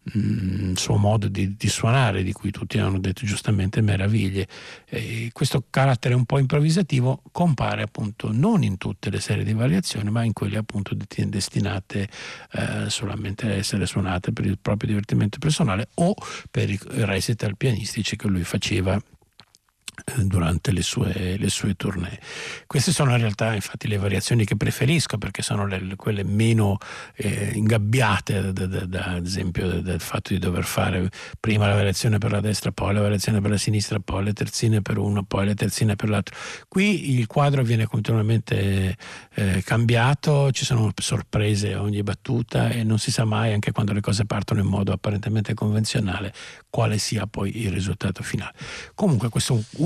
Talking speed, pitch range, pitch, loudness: 175 wpm, 100-115 Hz, 105 Hz, -23 LUFS